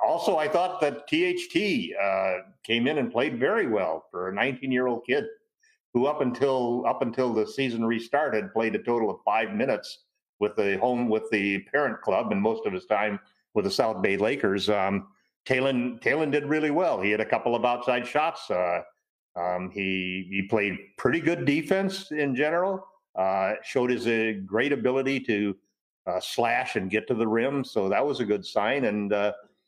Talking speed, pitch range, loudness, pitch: 185 wpm, 105-150 Hz, -26 LUFS, 120 Hz